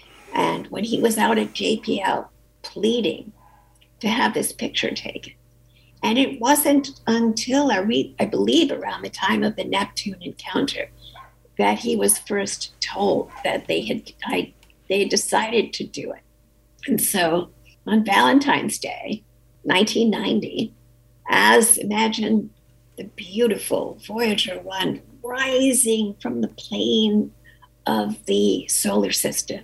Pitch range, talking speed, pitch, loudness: 170-240 Hz, 125 wpm, 215 Hz, -21 LUFS